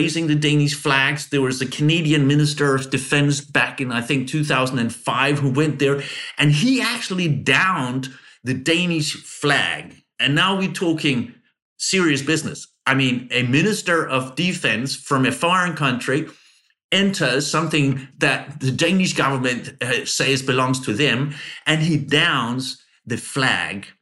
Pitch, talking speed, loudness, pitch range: 145 Hz, 145 wpm, -19 LUFS, 135-155 Hz